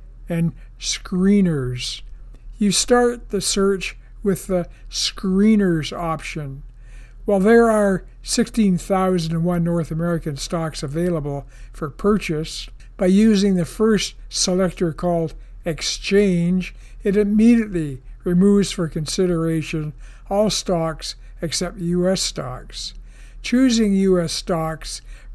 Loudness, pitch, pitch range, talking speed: -20 LUFS, 175 Hz, 150-195 Hz, 95 wpm